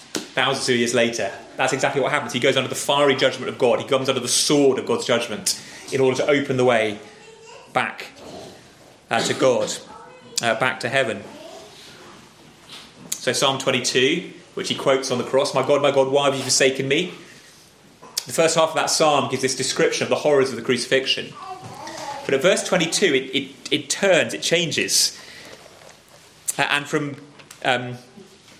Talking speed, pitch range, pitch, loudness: 185 wpm, 130-150 Hz, 135 Hz, -20 LUFS